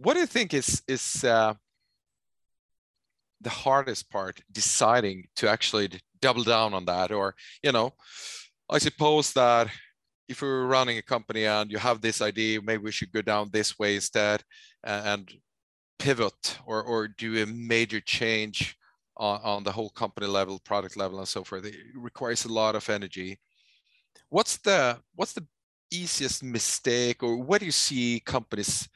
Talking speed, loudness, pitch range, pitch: 160 wpm, -27 LUFS, 105-130 Hz, 110 Hz